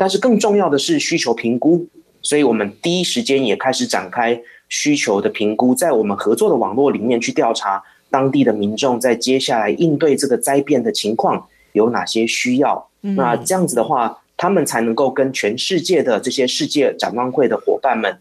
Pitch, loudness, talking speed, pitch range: 140 Hz, -17 LUFS, 305 characters per minute, 120-190 Hz